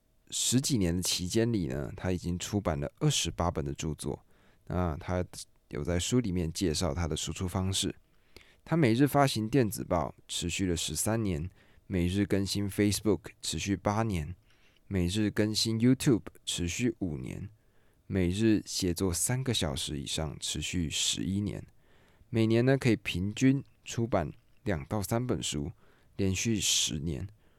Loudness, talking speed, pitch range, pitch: -30 LUFS, 250 characters per minute, 85-110 Hz, 95 Hz